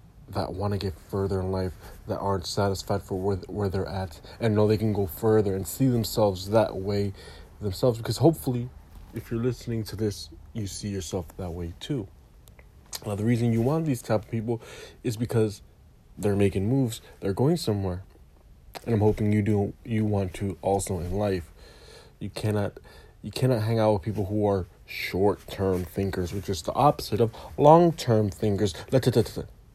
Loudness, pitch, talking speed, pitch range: -27 LUFS, 100 Hz, 175 wpm, 95-115 Hz